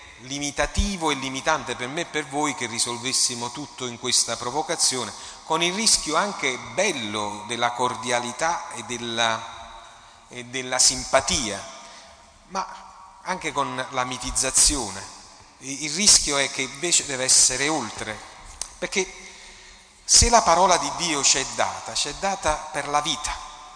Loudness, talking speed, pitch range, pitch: -22 LUFS, 135 wpm, 120-150 Hz, 130 Hz